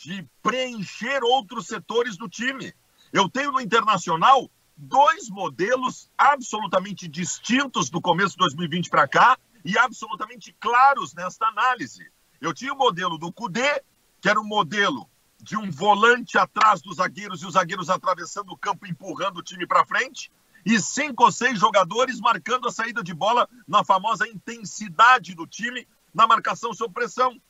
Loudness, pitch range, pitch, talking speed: -22 LUFS, 185-250 Hz, 215 Hz, 155 wpm